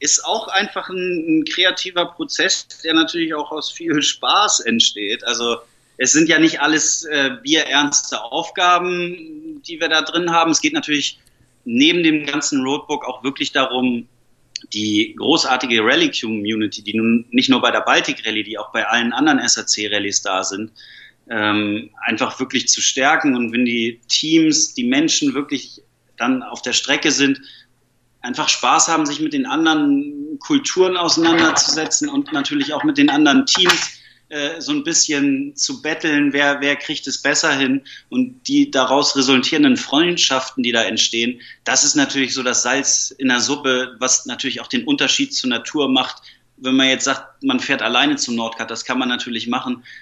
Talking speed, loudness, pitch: 170 wpm, -17 LUFS, 155 Hz